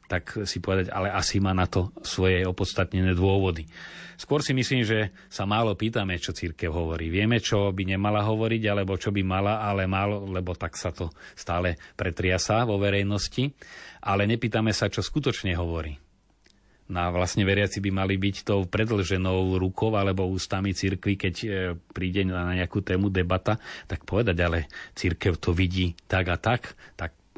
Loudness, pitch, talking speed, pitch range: -26 LUFS, 95 Hz, 165 wpm, 90-105 Hz